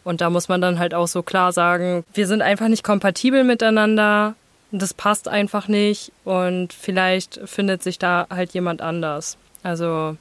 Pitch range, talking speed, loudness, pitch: 175-210 Hz, 170 wpm, -20 LUFS, 185 Hz